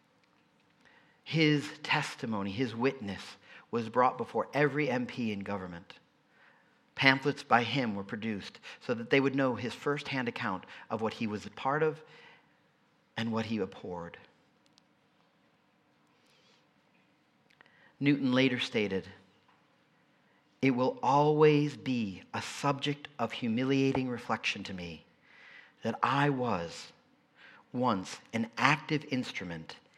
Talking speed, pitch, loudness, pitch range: 110 wpm, 125 Hz, -31 LUFS, 110-140 Hz